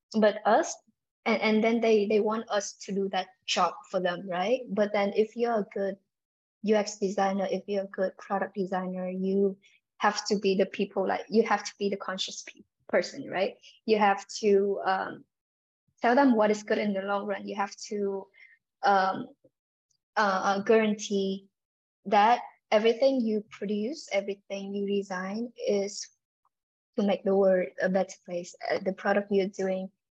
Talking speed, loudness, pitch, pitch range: 165 wpm, -28 LUFS, 200 Hz, 195-215 Hz